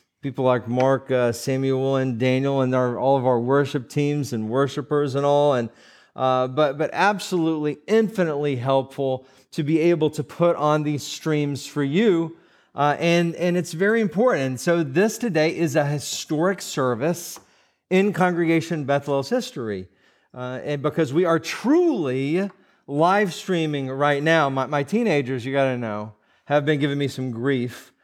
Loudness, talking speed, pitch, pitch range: -22 LUFS, 160 wpm, 145 Hz, 130-170 Hz